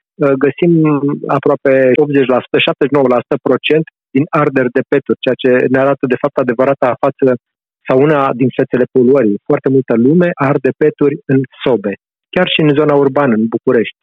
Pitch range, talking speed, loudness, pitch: 130-145 Hz, 145 wpm, -12 LUFS, 140 Hz